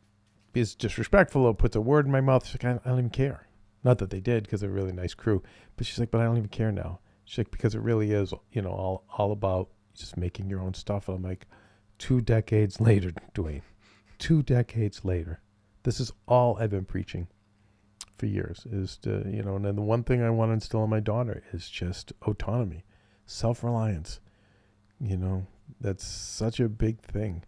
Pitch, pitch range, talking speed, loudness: 105 Hz, 95-115 Hz, 210 wpm, -28 LUFS